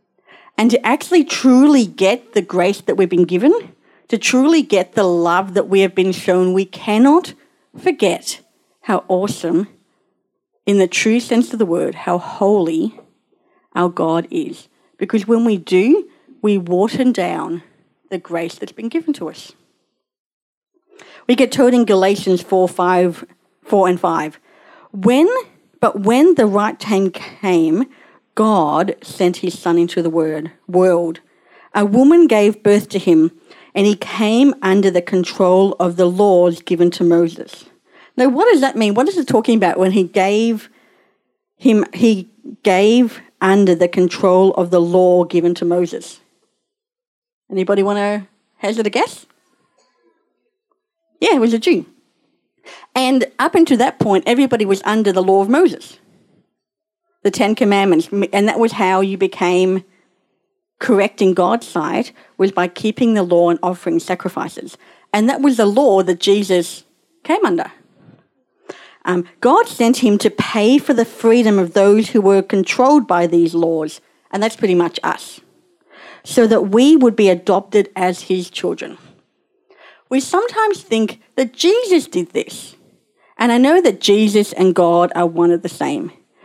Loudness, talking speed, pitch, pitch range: -15 LUFS, 155 wpm, 205 Hz, 185-260 Hz